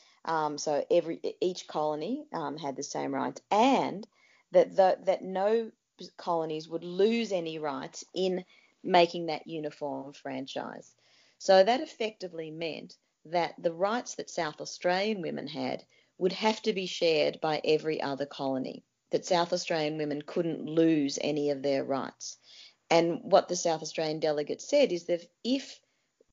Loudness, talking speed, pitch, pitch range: -30 LUFS, 150 wpm, 170 Hz, 155-190 Hz